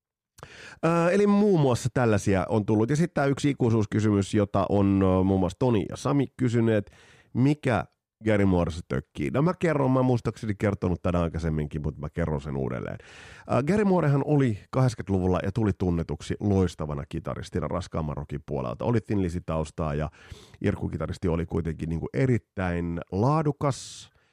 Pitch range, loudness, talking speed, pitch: 85-125 Hz, -26 LUFS, 145 wpm, 100 Hz